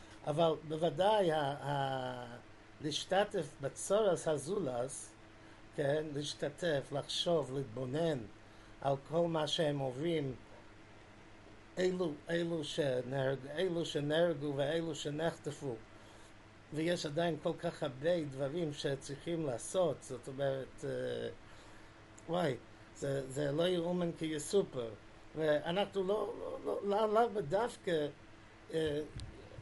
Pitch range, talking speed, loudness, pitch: 115-165 Hz, 95 wpm, -37 LUFS, 145 Hz